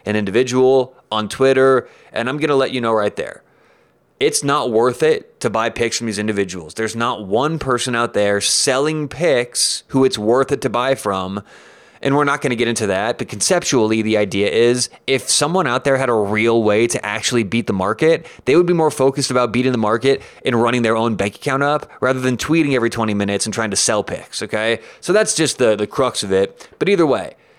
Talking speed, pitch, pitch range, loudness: 225 wpm, 120 Hz, 110-135 Hz, -17 LUFS